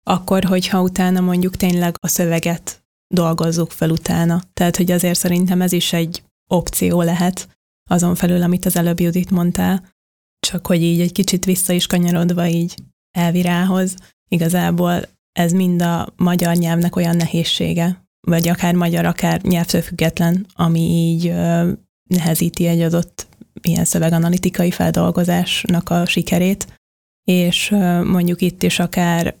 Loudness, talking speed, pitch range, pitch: -17 LUFS, 130 wpm, 170-180 Hz, 175 Hz